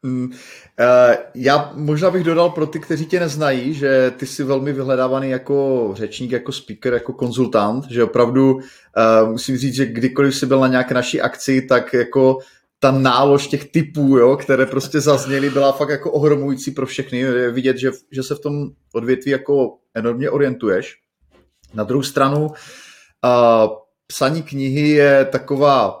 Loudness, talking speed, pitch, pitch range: -17 LUFS, 150 wpm, 135 Hz, 125-140 Hz